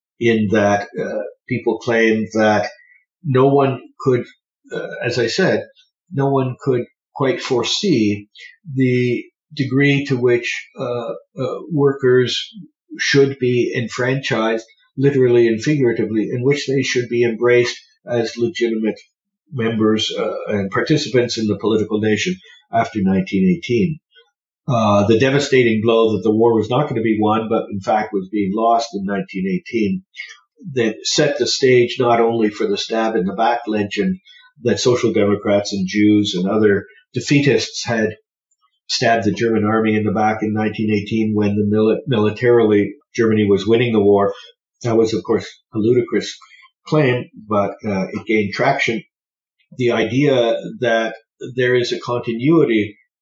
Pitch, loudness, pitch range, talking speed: 115 Hz, -18 LUFS, 110-135 Hz, 145 wpm